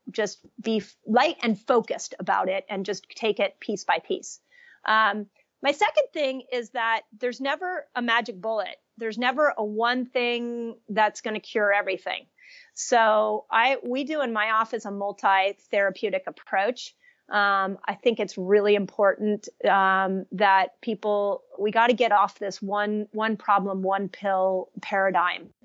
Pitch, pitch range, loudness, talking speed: 215 Hz, 200-245 Hz, -25 LUFS, 155 wpm